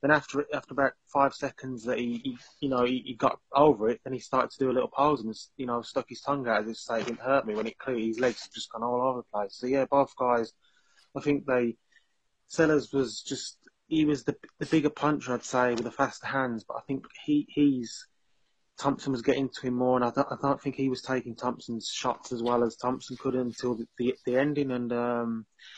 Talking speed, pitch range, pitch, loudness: 245 wpm, 120-140 Hz, 130 Hz, -29 LUFS